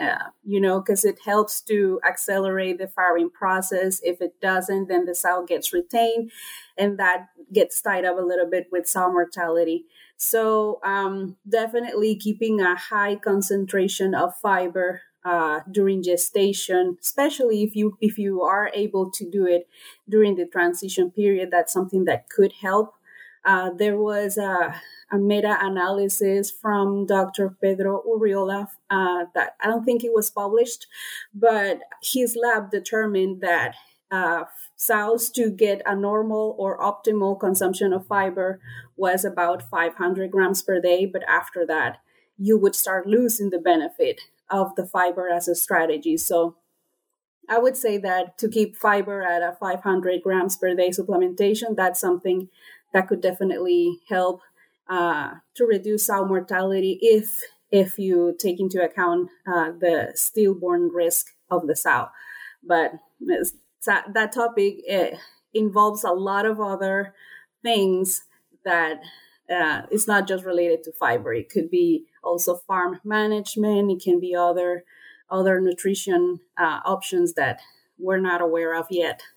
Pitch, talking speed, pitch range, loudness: 195 Hz, 145 wpm, 180-210 Hz, -22 LUFS